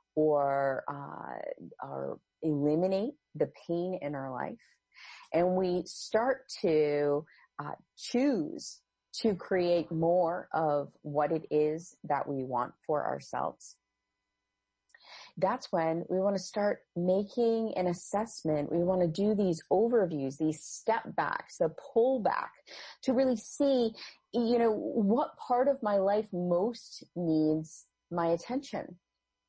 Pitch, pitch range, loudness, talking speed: 175 Hz, 150-220 Hz, -31 LUFS, 120 wpm